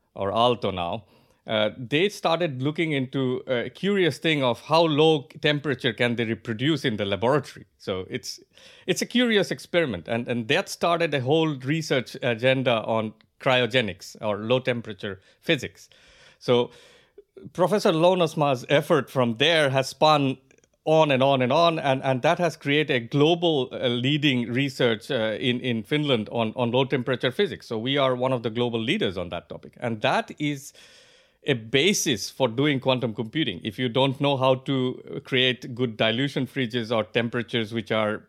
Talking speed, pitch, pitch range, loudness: 165 wpm, 130 Hz, 120-155 Hz, -24 LUFS